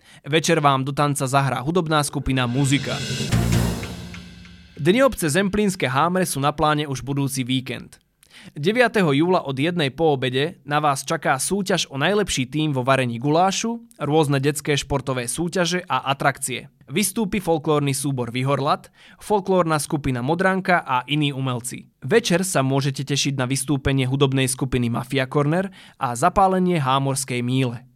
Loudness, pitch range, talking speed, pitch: -21 LUFS, 130-170 Hz, 135 wpm, 145 Hz